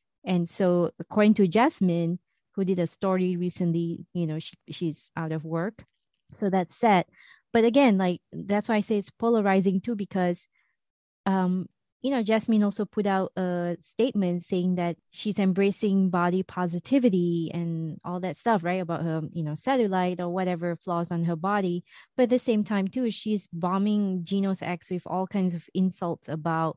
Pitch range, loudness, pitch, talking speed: 175-205 Hz, -27 LUFS, 185 Hz, 175 wpm